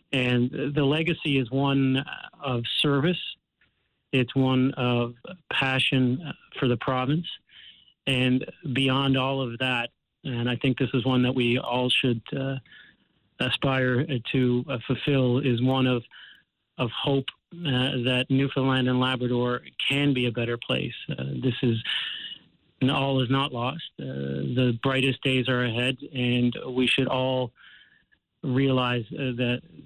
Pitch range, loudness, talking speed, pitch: 125-135 Hz, -25 LUFS, 145 wpm, 130 Hz